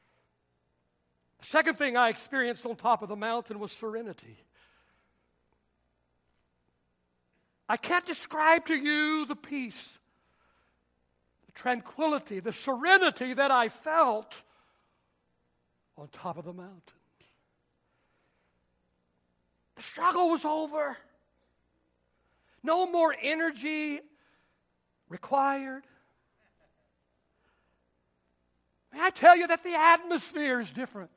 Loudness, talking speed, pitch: -27 LUFS, 90 wpm, 190 Hz